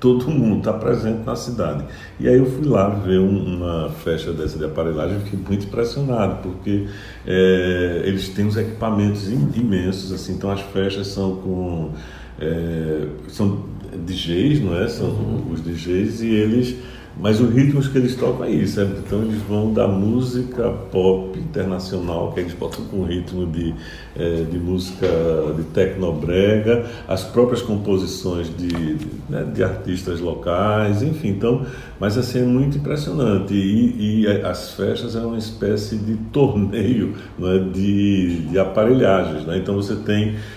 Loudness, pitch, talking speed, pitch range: -20 LUFS, 100 Hz, 160 wpm, 90-110 Hz